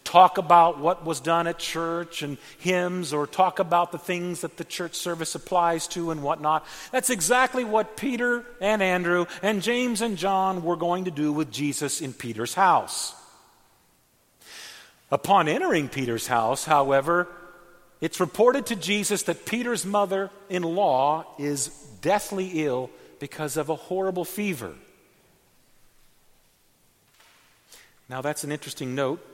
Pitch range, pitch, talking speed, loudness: 150-195 Hz, 175 Hz, 140 wpm, -25 LUFS